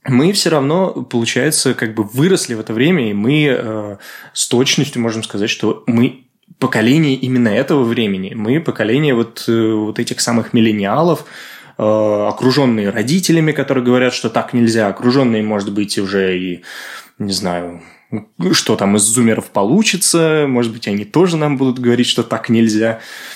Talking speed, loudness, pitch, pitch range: 155 wpm, -15 LUFS, 120 Hz, 105-135 Hz